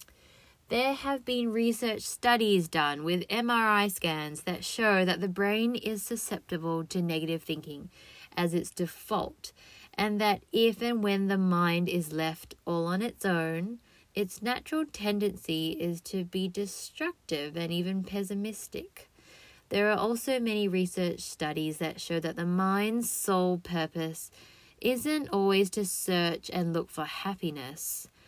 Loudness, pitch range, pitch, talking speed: -30 LUFS, 170-215 Hz, 190 Hz, 140 wpm